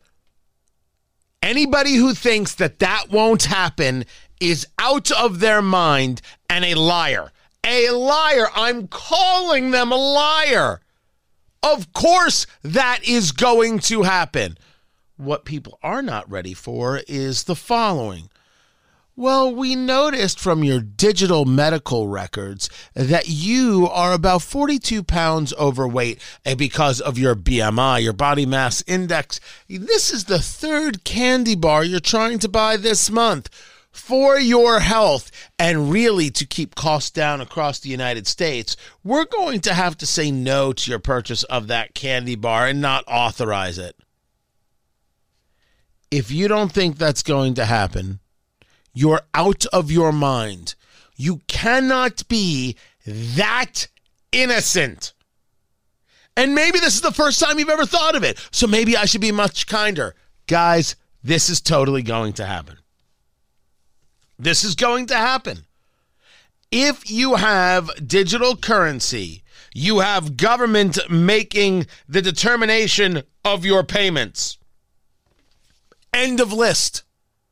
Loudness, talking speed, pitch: -18 LUFS, 130 wpm, 180 Hz